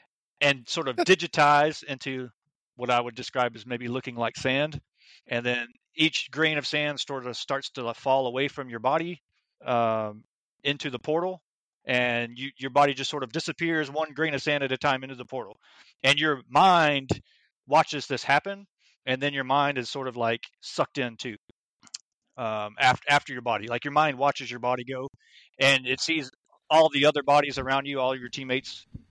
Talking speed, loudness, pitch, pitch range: 190 wpm, -26 LUFS, 135 Hz, 125-145 Hz